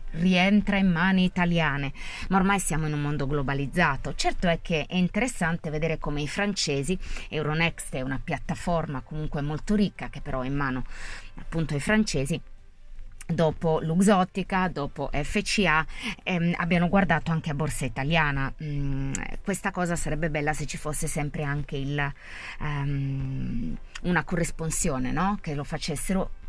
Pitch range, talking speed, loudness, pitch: 140-180 Hz, 145 wpm, -27 LUFS, 155 Hz